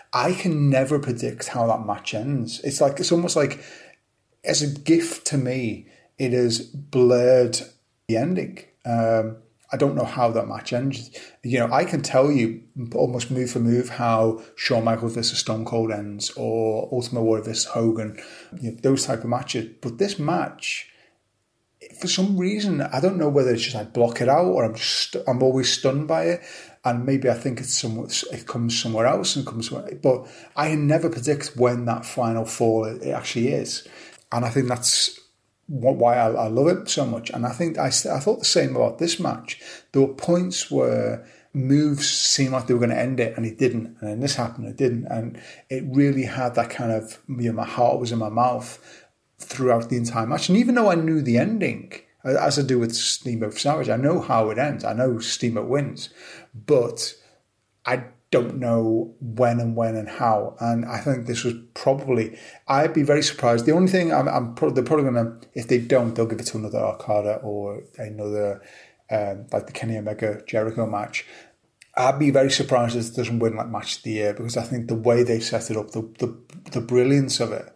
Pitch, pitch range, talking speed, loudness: 120 Hz, 115-135 Hz, 205 wpm, -23 LUFS